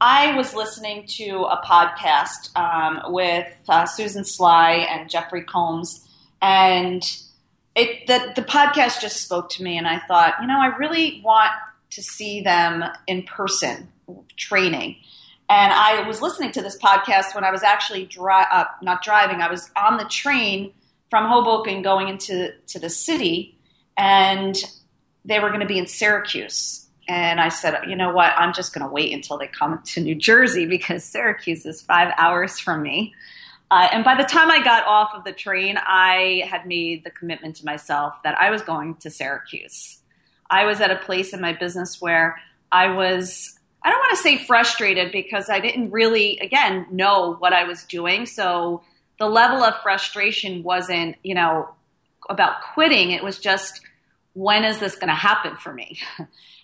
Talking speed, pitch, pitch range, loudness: 180 wpm, 190 Hz, 175-215 Hz, -19 LUFS